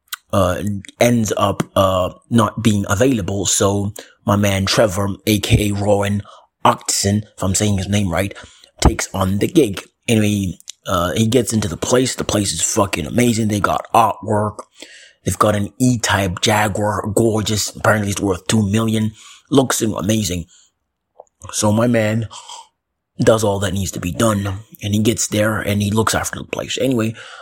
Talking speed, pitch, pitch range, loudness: 160 wpm, 105 Hz, 100-110 Hz, -17 LUFS